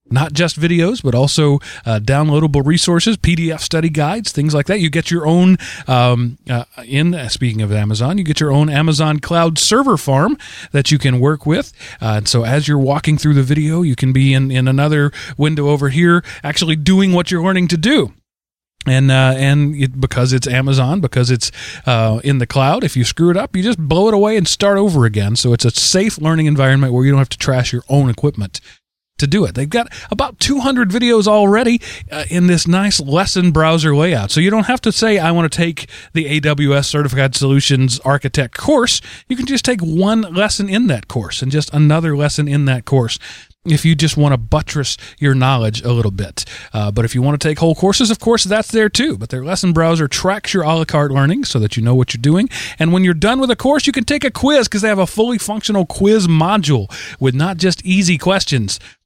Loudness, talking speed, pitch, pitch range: -14 LUFS, 225 wpm, 150 Hz, 130-185 Hz